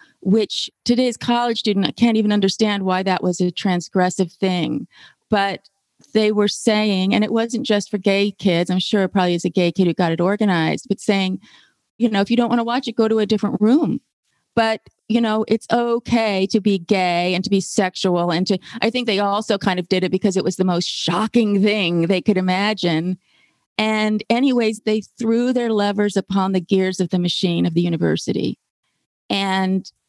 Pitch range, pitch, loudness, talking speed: 185-220 Hz, 200 Hz, -19 LUFS, 200 wpm